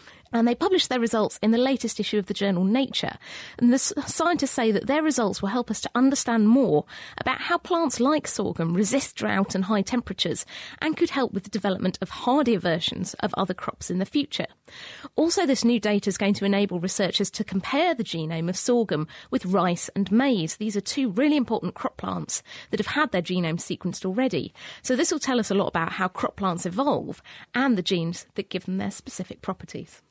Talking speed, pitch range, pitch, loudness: 210 wpm, 190-260 Hz, 215 Hz, -25 LUFS